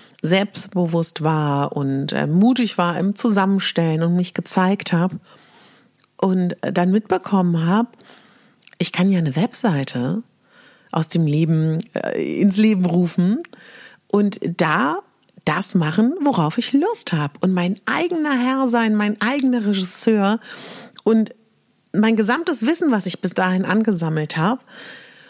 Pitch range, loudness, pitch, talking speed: 175-230 Hz, -19 LUFS, 195 Hz, 130 wpm